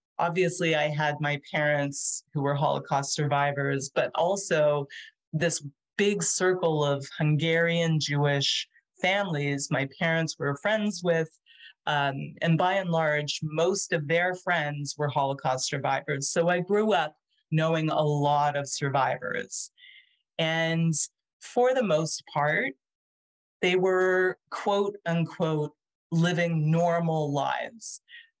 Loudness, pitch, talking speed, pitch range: -27 LUFS, 160 Hz, 120 wpm, 145-180 Hz